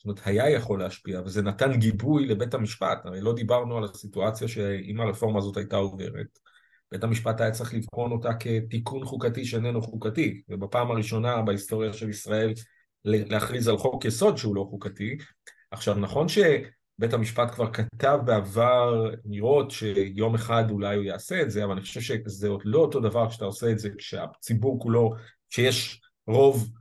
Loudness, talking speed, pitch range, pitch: -26 LUFS, 165 wpm, 105-120 Hz, 110 Hz